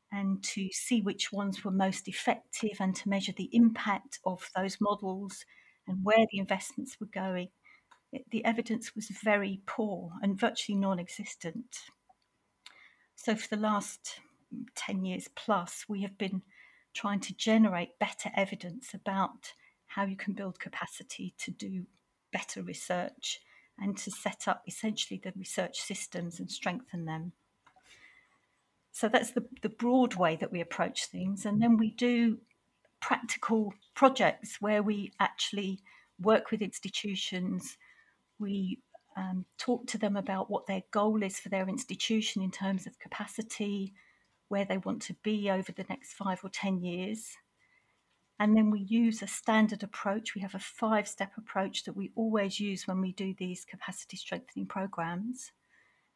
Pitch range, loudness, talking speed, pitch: 190-220 Hz, -33 LUFS, 155 wpm, 200 Hz